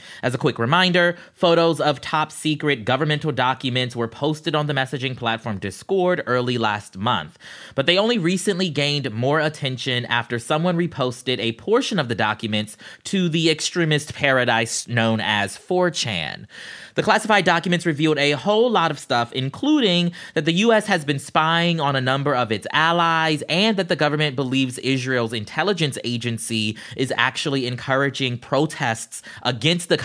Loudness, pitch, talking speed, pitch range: -21 LUFS, 145 Hz, 155 wpm, 125-170 Hz